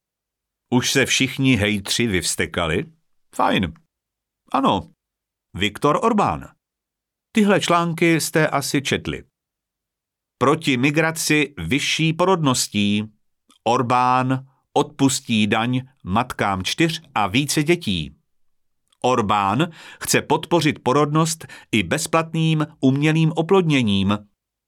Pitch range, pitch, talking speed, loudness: 120-160 Hz, 140 Hz, 85 wpm, -20 LUFS